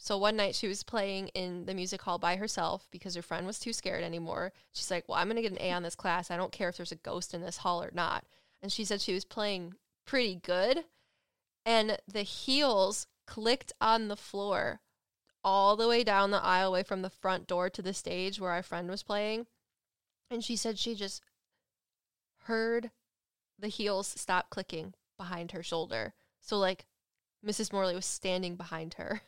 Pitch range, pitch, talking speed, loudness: 180-210 Hz, 195 Hz, 200 wpm, -33 LUFS